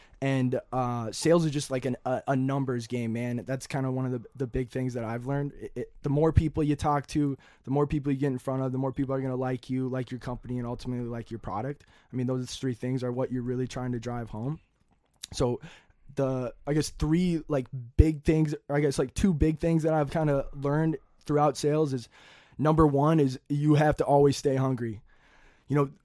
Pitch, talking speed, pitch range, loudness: 135 Hz, 235 wpm, 125-150 Hz, -28 LUFS